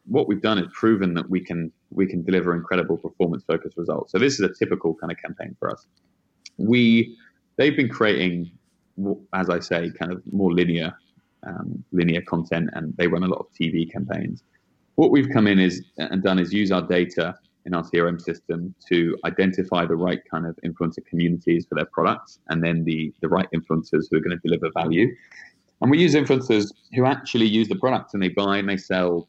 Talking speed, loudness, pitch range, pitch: 205 wpm, -23 LUFS, 85-100 Hz, 90 Hz